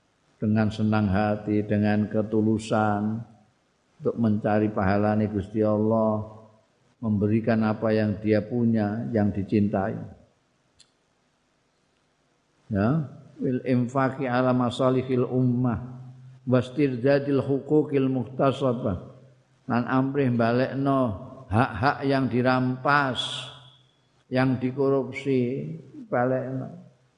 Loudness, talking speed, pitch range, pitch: -25 LUFS, 80 wpm, 110-130 Hz, 125 Hz